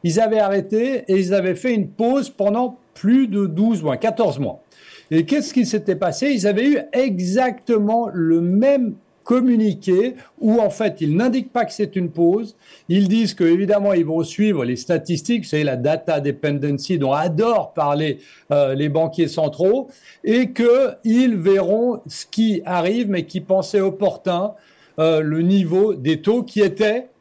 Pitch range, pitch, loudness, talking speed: 170-230 Hz, 200 Hz, -19 LUFS, 170 wpm